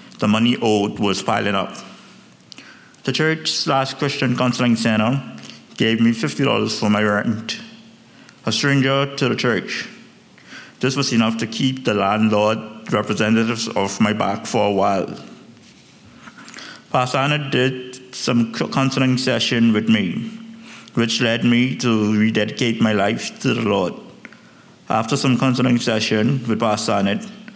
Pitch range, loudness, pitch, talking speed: 110-135 Hz, -19 LUFS, 120 Hz, 135 wpm